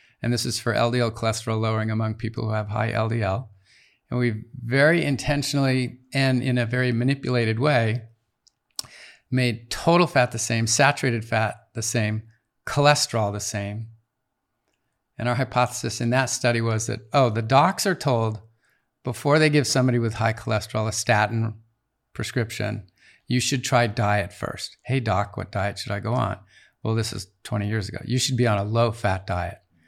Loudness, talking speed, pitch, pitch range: -23 LUFS, 170 wpm, 115 Hz, 110-125 Hz